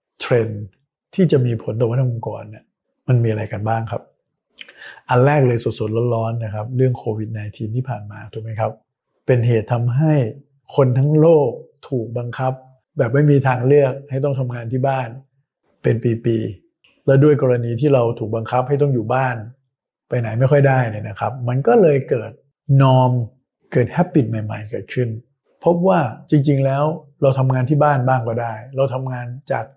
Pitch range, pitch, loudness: 115-140 Hz, 125 Hz, -18 LUFS